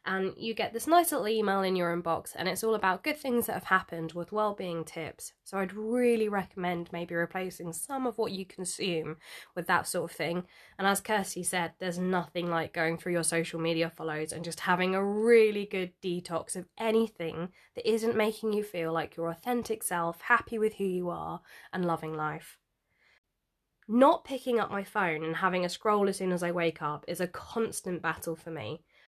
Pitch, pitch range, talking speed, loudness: 180 Hz, 165-215 Hz, 200 wpm, -31 LUFS